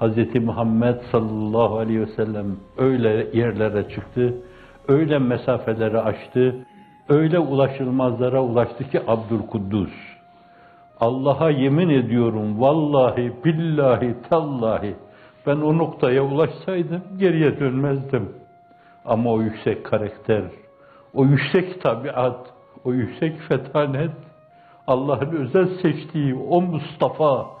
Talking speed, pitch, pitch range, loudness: 95 wpm, 130 Hz, 115-155 Hz, -21 LUFS